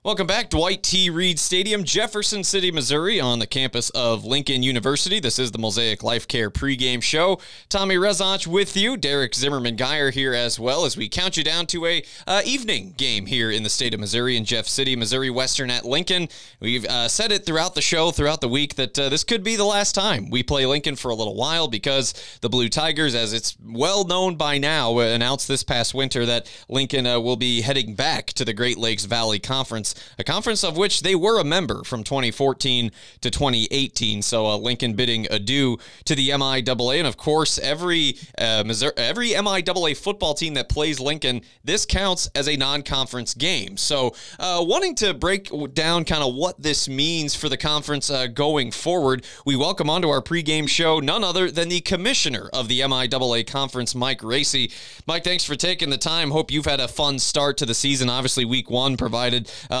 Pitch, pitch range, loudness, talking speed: 135 Hz, 120-165 Hz, -21 LUFS, 205 wpm